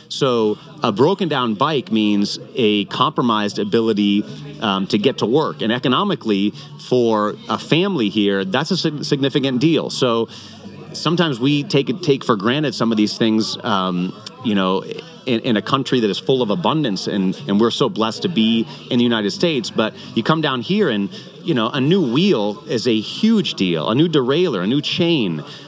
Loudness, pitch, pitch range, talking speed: -18 LUFS, 115 Hz, 105-145 Hz, 185 wpm